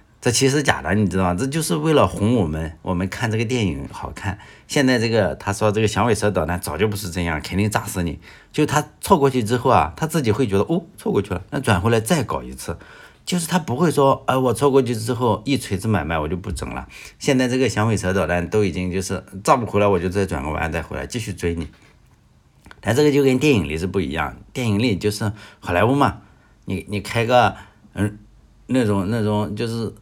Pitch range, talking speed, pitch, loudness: 95-125 Hz, 325 characters per minute, 105 Hz, -20 LUFS